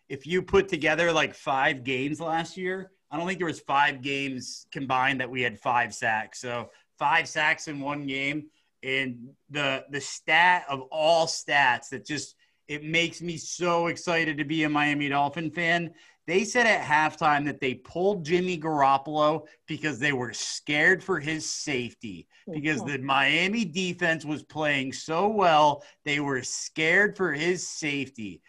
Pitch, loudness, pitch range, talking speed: 150 Hz, -26 LUFS, 135-170 Hz, 165 wpm